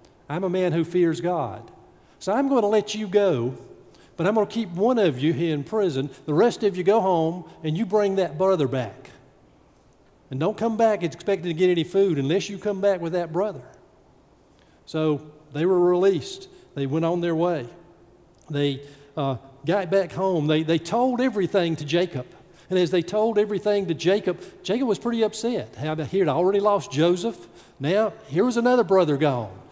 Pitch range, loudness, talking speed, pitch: 150-205 Hz, -23 LUFS, 190 wpm, 175 Hz